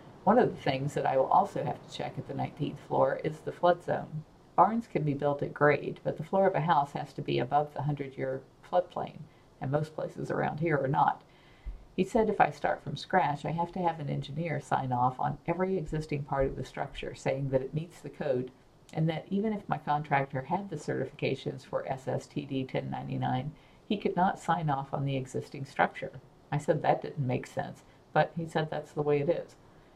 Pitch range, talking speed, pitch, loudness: 140-170 Hz, 215 wpm, 150 Hz, -31 LUFS